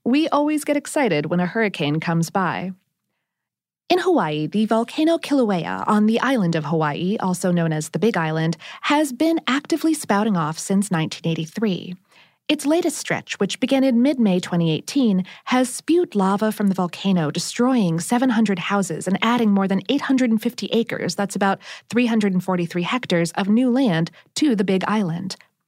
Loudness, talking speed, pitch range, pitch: -21 LUFS, 155 wpm, 175-255 Hz, 205 Hz